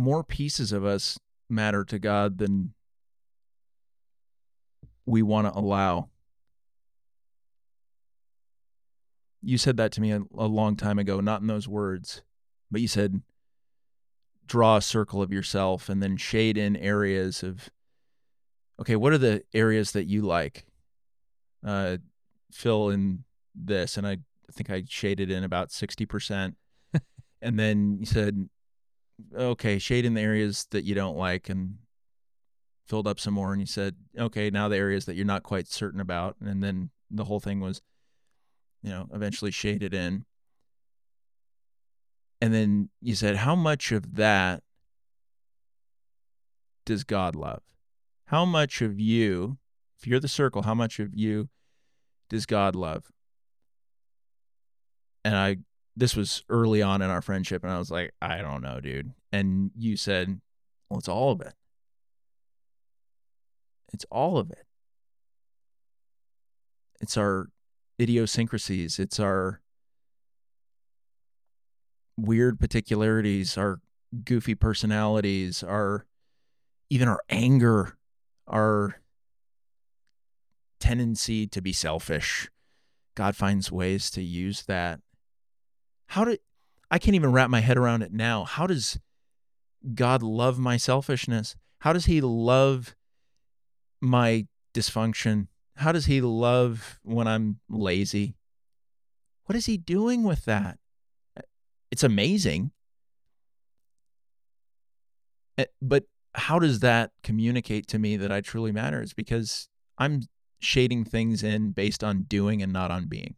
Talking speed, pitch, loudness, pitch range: 130 wpm, 105 Hz, -27 LUFS, 100-120 Hz